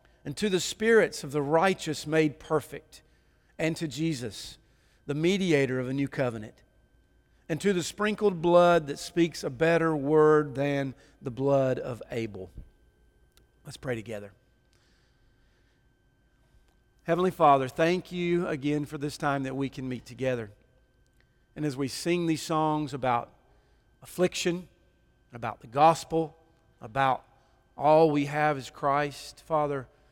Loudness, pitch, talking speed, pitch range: -27 LUFS, 145 Hz, 135 wpm, 130-160 Hz